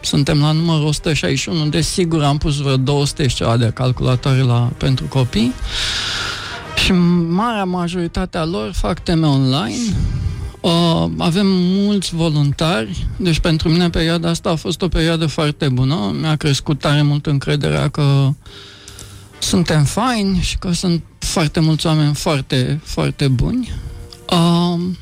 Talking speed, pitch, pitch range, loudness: 135 wpm, 155 Hz, 135-175 Hz, -17 LUFS